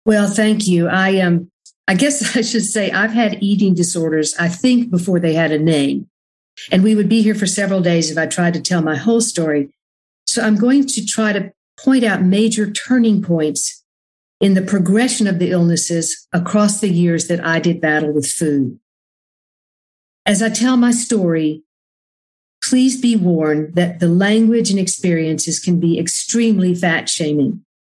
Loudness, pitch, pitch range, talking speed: -16 LUFS, 185 Hz, 165-215 Hz, 175 wpm